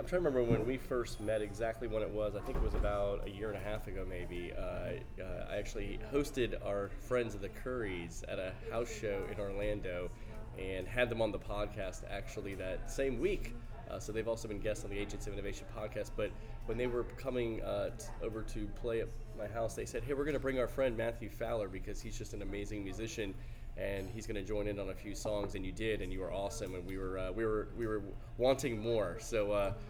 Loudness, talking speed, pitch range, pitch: -39 LUFS, 245 wpm, 100-115 Hz, 110 Hz